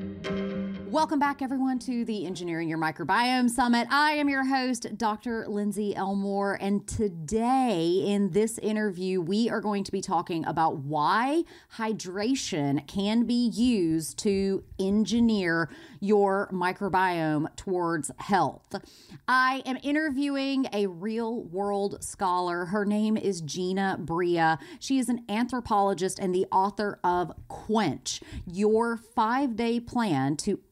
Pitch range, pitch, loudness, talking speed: 185-235 Hz, 205 Hz, -27 LUFS, 125 wpm